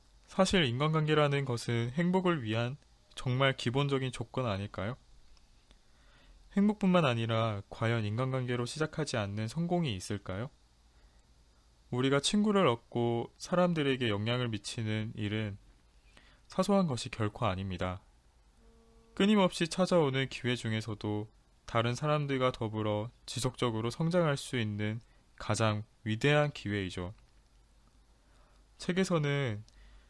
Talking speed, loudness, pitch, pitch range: 265 characters per minute, -32 LUFS, 120 Hz, 105-145 Hz